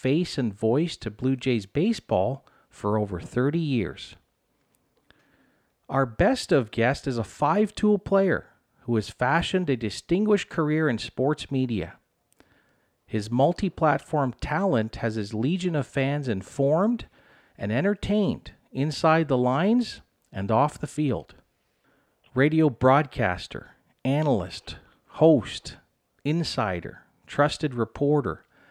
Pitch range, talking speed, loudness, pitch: 115-160 Hz, 115 wpm, -25 LUFS, 135 Hz